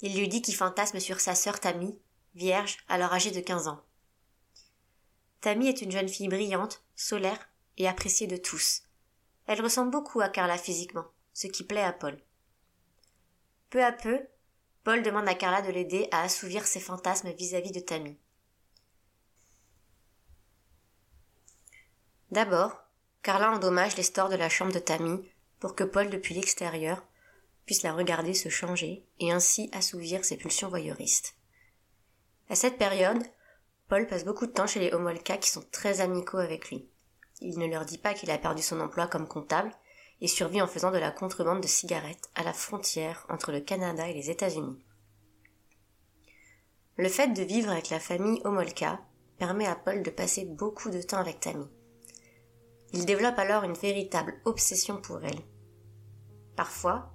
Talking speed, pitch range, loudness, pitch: 160 wpm, 115-195 Hz, -30 LUFS, 180 Hz